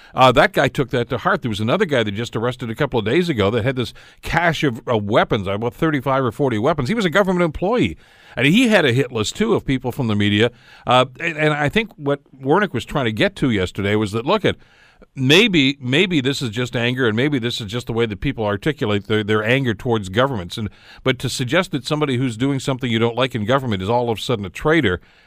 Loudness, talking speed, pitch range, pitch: -19 LUFS, 250 wpm, 115-140 Hz, 125 Hz